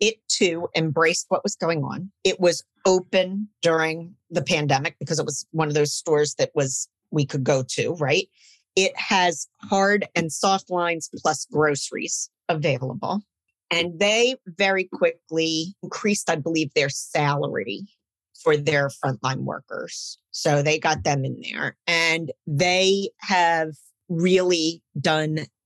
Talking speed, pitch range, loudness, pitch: 140 wpm, 150-185 Hz, -23 LUFS, 165 Hz